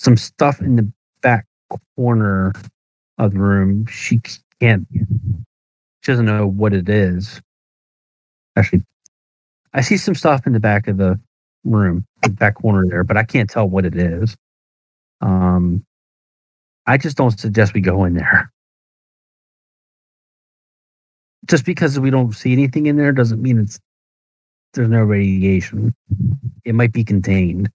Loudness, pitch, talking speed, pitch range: -17 LUFS, 110 Hz, 145 wpm, 95-120 Hz